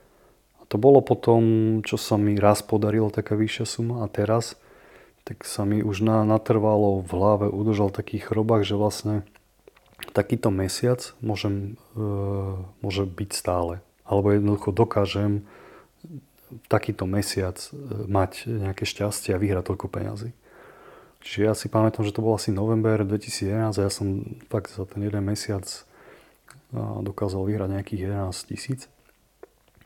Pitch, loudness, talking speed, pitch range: 105 Hz, -25 LUFS, 140 wpm, 100-110 Hz